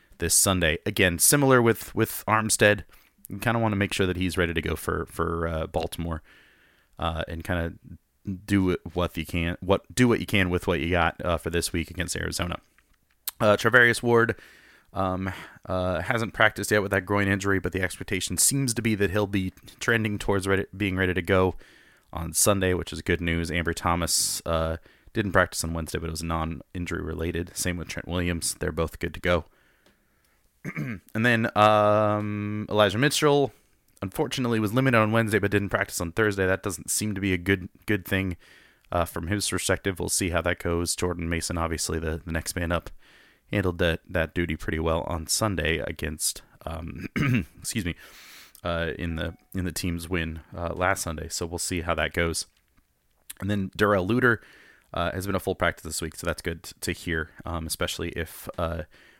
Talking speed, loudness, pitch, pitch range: 195 wpm, -26 LUFS, 90 Hz, 85-100 Hz